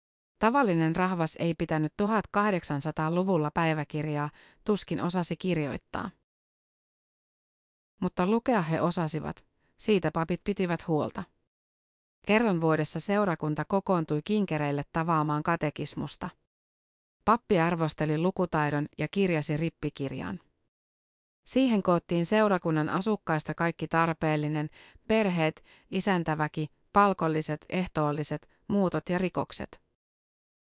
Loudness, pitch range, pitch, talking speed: -28 LUFS, 150-185 Hz, 165 Hz, 85 wpm